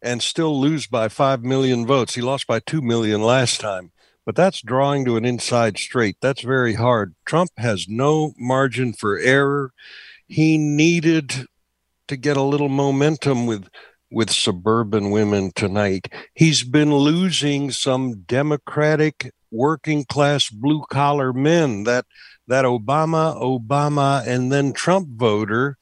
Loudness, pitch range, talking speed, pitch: -19 LUFS, 115-145 Hz, 140 wpm, 130 Hz